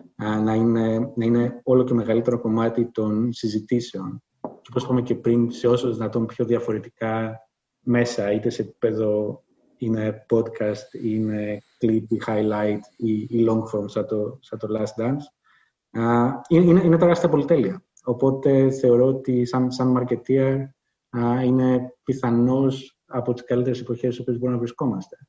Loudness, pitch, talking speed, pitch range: -22 LUFS, 120 Hz, 140 wpm, 110-125 Hz